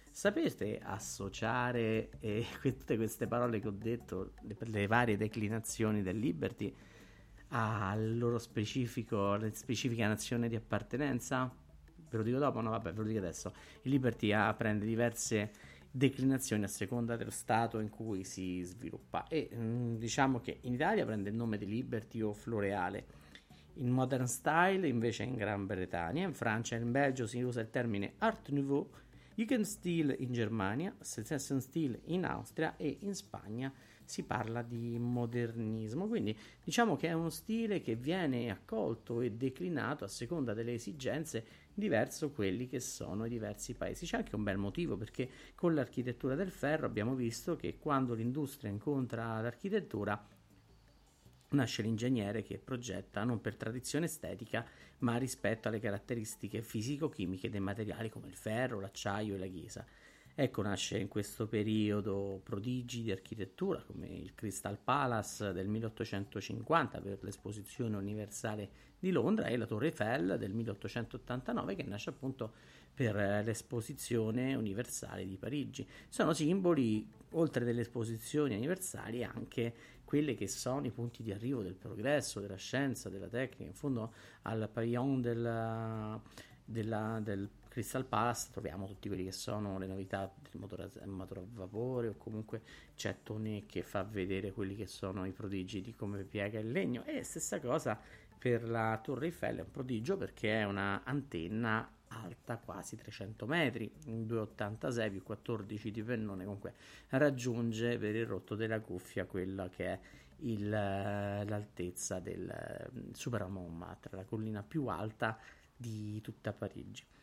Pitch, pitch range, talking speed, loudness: 115 Hz, 105-125 Hz, 145 wpm, -38 LUFS